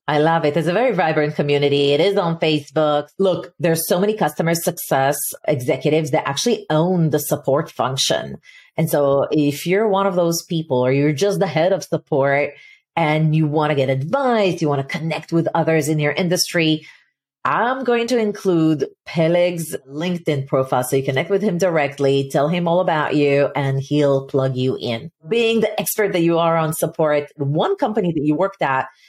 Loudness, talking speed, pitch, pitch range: -19 LUFS, 190 wpm, 160 Hz, 145-180 Hz